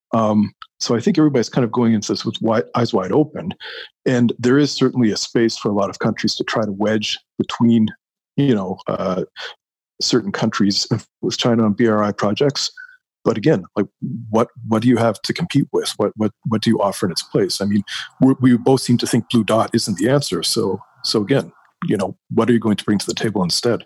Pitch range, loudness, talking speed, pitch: 105-130 Hz, -18 LUFS, 225 wpm, 115 Hz